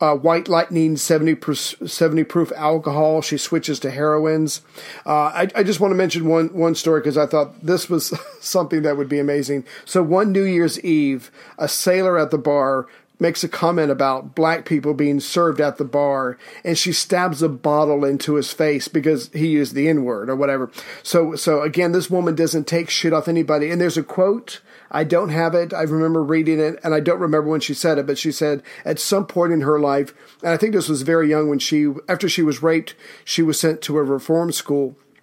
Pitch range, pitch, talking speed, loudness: 150-170 Hz, 160 Hz, 215 wpm, -19 LUFS